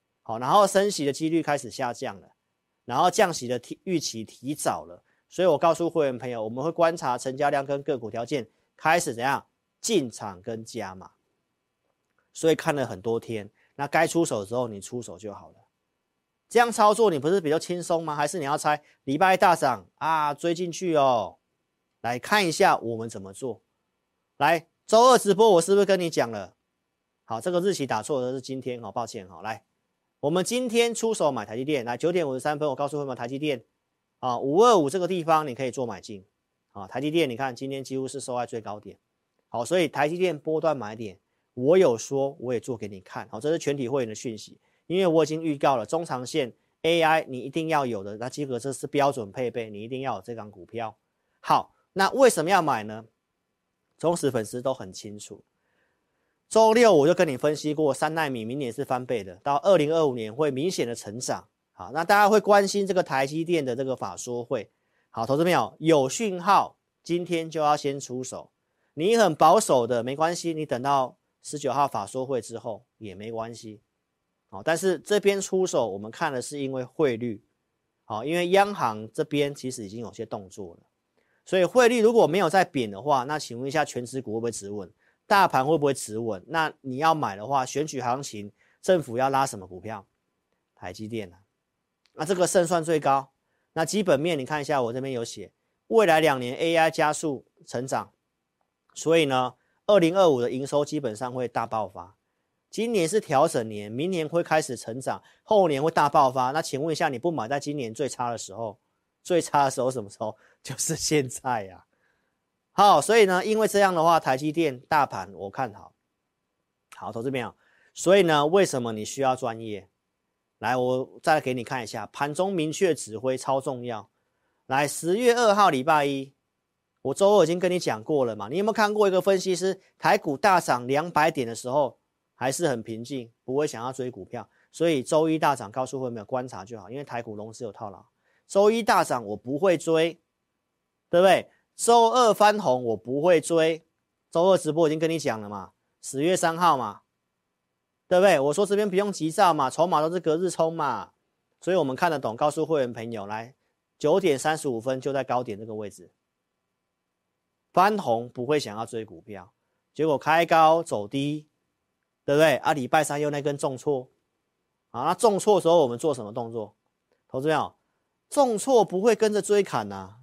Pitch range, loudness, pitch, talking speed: 115-165 Hz, -25 LUFS, 140 Hz, 285 characters per minute